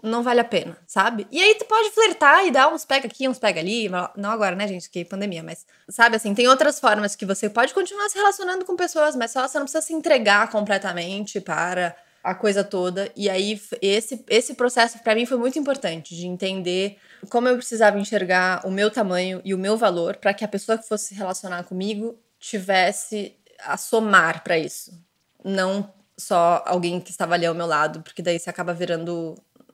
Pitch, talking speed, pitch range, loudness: 205 Hz, 205 wpm, 185-240 Hz, -21 LUFS